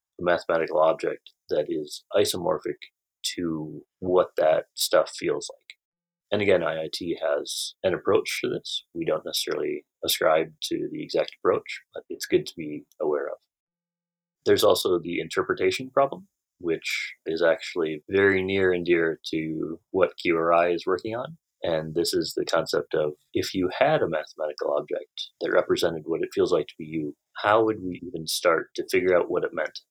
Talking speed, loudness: 170 wpm, -26 LUFS